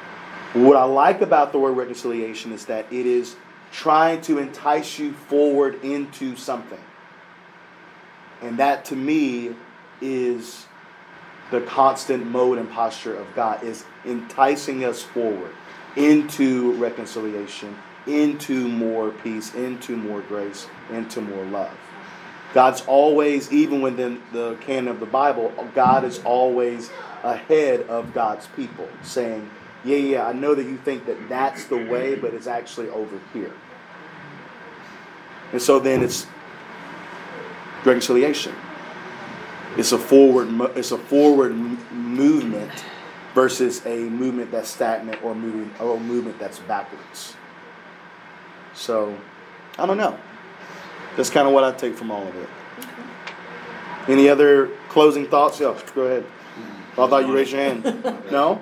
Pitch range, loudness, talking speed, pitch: 115-140 Hz, -21 LUFS, 130 wpm, 130 Hz